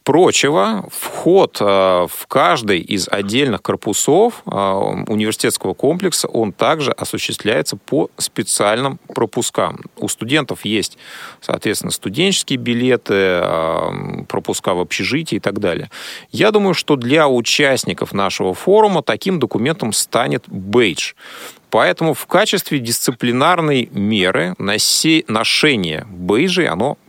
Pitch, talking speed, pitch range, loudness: 120 Hz, 100 wpm, 100-160 Hz, -16 LUFS